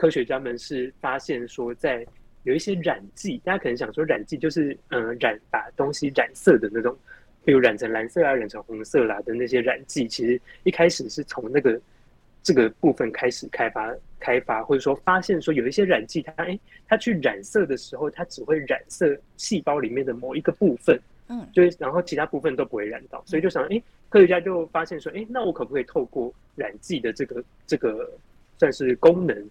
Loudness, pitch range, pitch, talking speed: -24 LUFS, 130-185 Hz, 160 Hz, 315 characters per minute